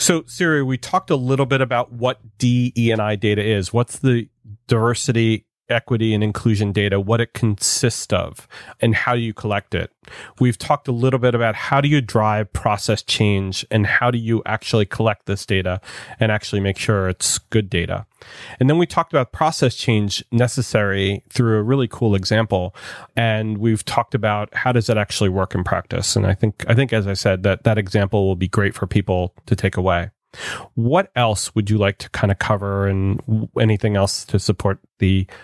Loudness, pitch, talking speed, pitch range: -19 LUFS, 110 Hz, 195 wpm, 100-120 Hz